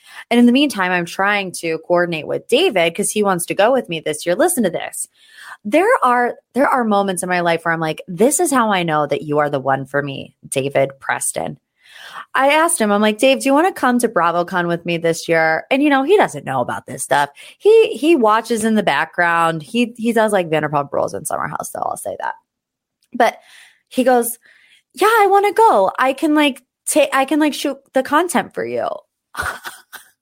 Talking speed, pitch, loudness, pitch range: 220 wpm, 225 Hz, -17 LUFS, 170-285 Hz